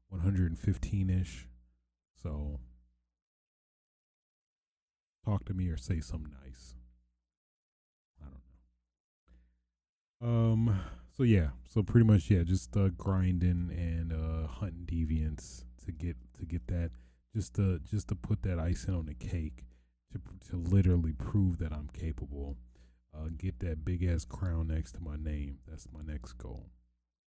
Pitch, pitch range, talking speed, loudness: 80 Hz, 60-90 Hz, 135 wpm, -34 LUFS